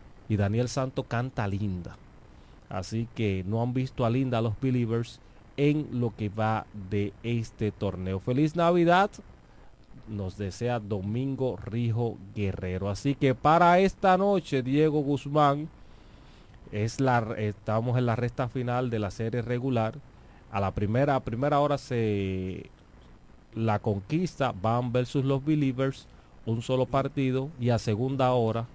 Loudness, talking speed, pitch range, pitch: -28 LUFS, 140 wpm, 105-135 Hz, 120 Hz